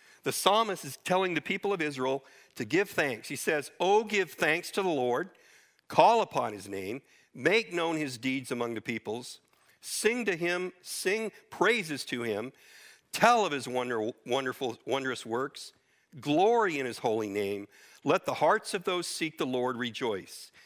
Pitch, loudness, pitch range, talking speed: 165 Hz, -30 LUFS, 130-200 Hz, 170 wpm